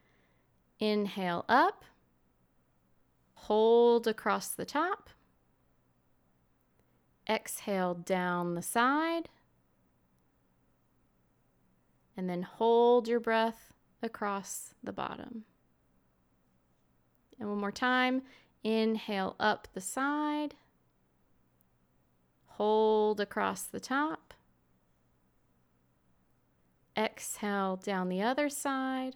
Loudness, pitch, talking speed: -31 LUFS, 180 Hz, 70 wpm